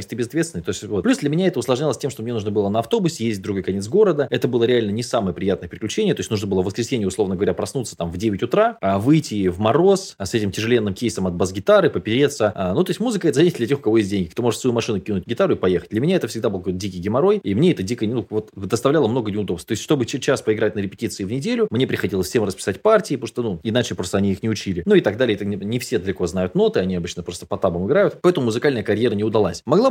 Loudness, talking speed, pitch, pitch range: -20 LUFS, 275 wpm, 115 Hz, 100-140 Hz